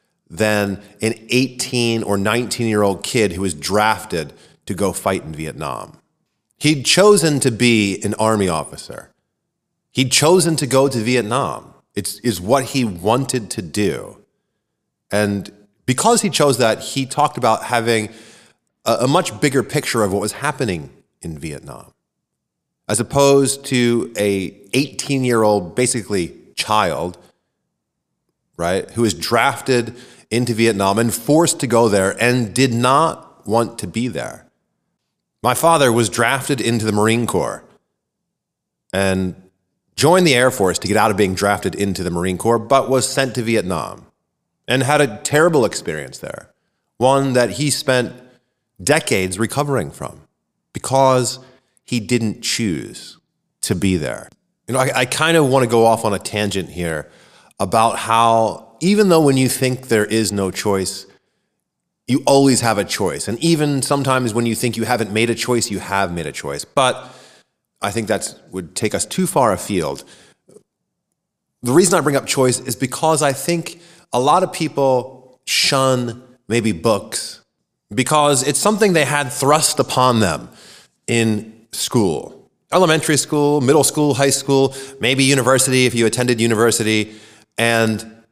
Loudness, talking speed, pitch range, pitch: -17 LUFS, 150 wpm, 110-135 Hz, 120 Hz